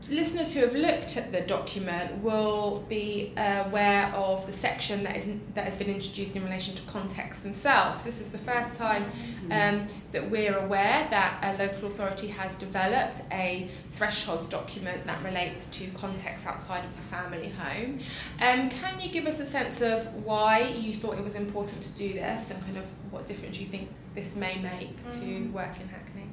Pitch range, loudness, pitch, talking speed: 190-215 Hz, -30 LUFS, 200 Hz, 190 wpm